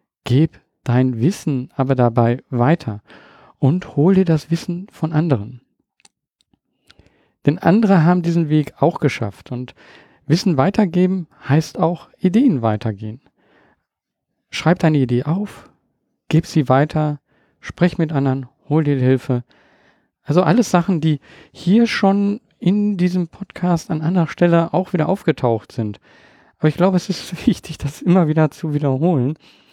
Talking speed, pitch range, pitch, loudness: 135 wpm, 135-180 Hz, 160 Hz, -18 LUFS